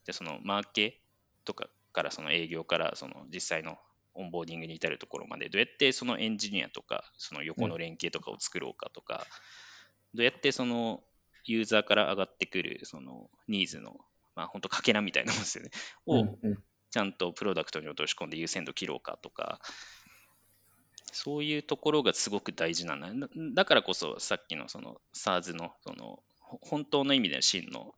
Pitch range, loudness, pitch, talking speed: 85-125 Hz, -32 LUFS, 105 Hz, 365 characters per minute